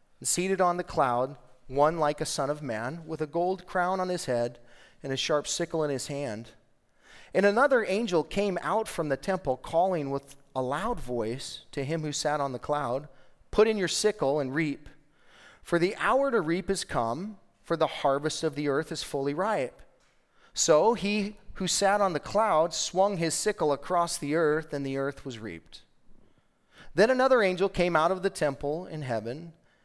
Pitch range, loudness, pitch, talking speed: 135-185 Hz, -28 LUFS, 155 Hz, 190 wpm